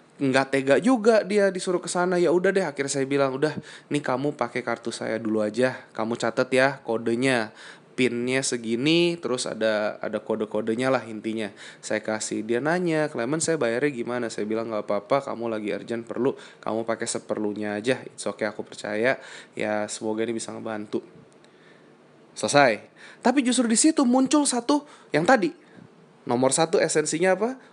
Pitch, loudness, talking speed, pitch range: 125 Hz, -25 LUFS, 165 wpm, 110-160 Hz